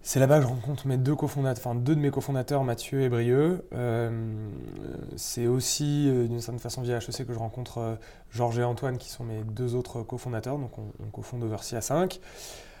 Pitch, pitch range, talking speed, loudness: 125 Hz, 115-135 Hz, 200 wpm, -29 LUFS